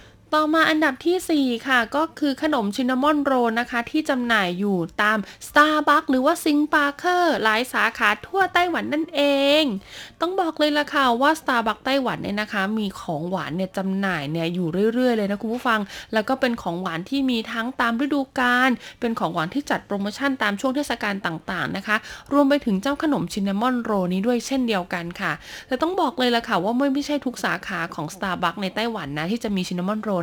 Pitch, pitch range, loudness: 235 Hz, 200-285 Hz, -22 LUFS